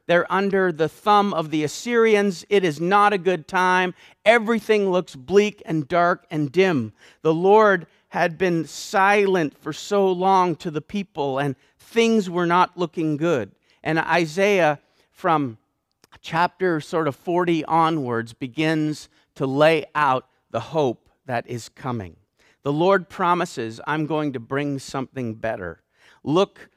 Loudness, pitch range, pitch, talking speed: -21 LUFS, 145-190 Hz, 165 Hz, 145 wpm